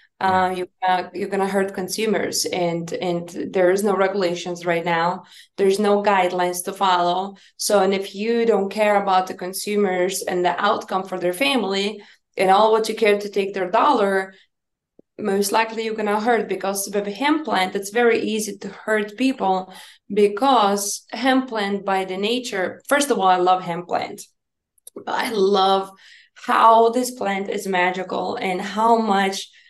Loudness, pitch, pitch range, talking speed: -20 LUFS, 195 Hz, 185-215 Hz, 170 wpm